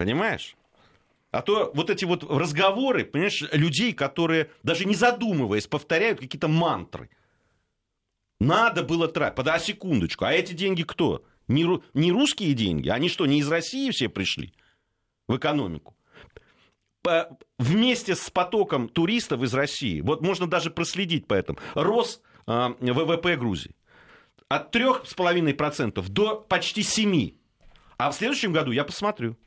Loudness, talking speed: -25 LUFS, 135 wpm